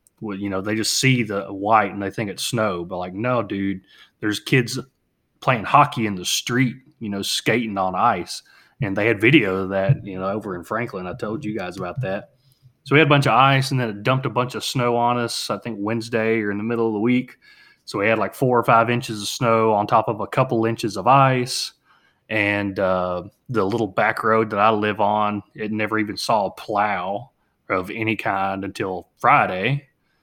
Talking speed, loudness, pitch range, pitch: 220 wpm, -21 LUFS, 100-125 Hz, 110 Hz